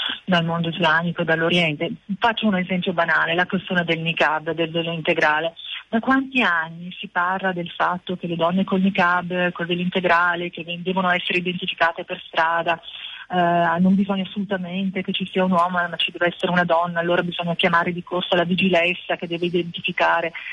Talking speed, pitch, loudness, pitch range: 185 wpm, 175 Hz, -21 LUFS, 170-185 Hz